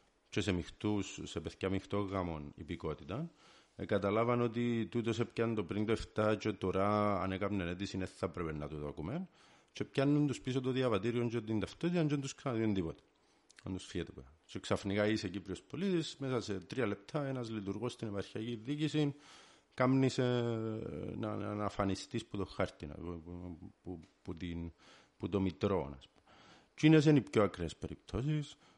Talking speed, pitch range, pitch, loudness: 165 wpm, 95-120 Hz, 105 Hz, -36 LUFS